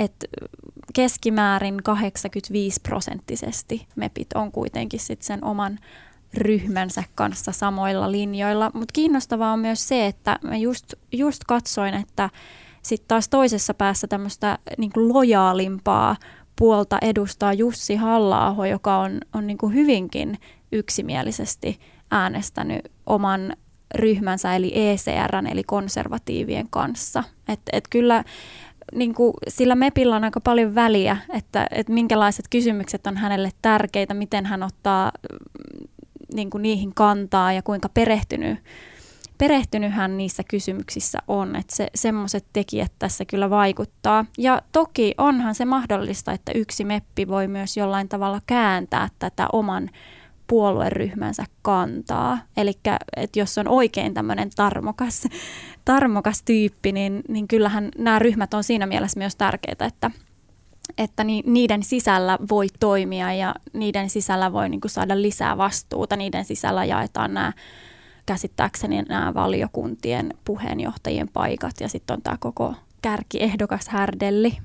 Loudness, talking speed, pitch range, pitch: -22 LUFS, 125 wpm, 195-230 Hz, 210 Hz